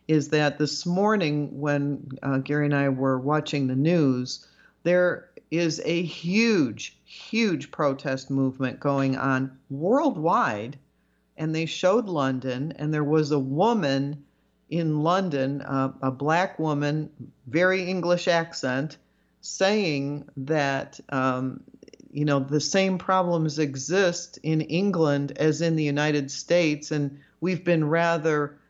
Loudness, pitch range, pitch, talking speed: -25 LUFS, 140-170 Hz, 150 Hz, 130 wpm